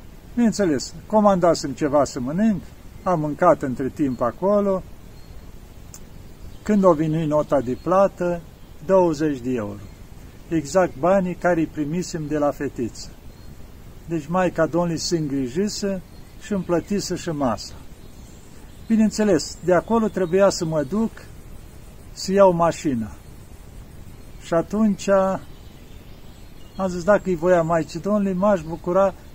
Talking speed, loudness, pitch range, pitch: 120 wpm, -21 LUFS, 130-190 Hz, 170 Hz